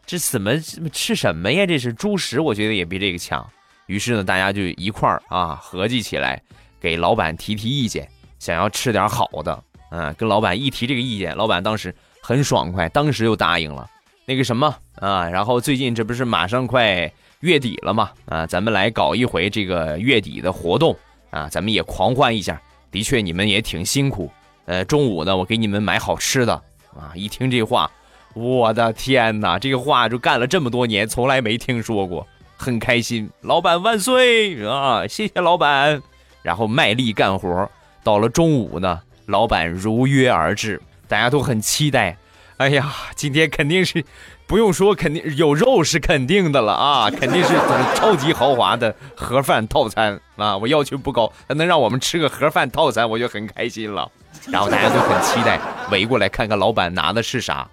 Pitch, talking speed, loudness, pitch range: 115 Hz, 275 characters per minute, -19 LUFS, 100-140 Hz